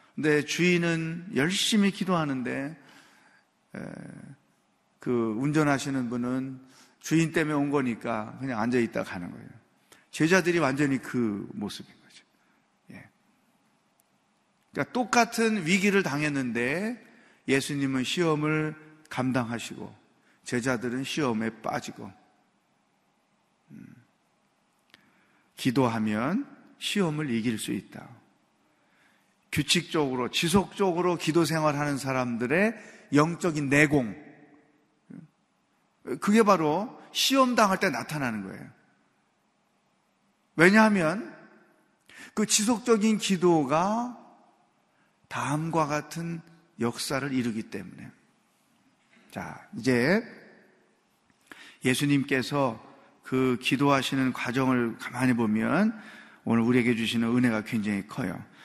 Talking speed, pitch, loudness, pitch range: 215 characters per minute, 150 Hz, -26 LUFS, 130-185 Hz